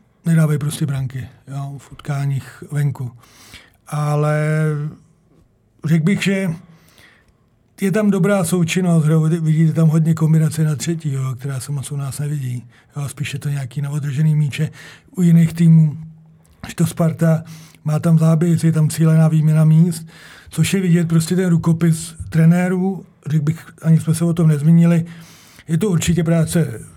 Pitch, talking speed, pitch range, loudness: 160 Hz, 155 wpm, 145-165 Hz, -17 LUFS